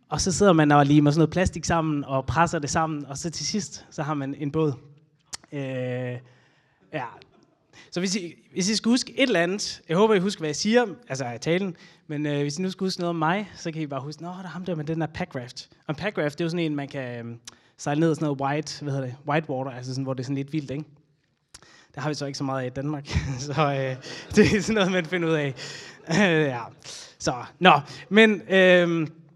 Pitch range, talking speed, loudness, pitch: 140-175 Hz, 260 wpm, -24 LUFS, 155 Hz